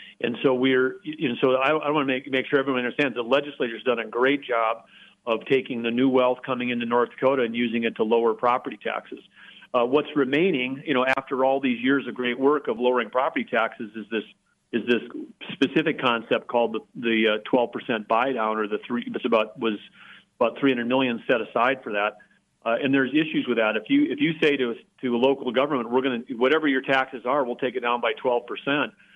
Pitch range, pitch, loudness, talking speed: 120-135 Hz, 130 Hz, -24 LUFS, 220 wpm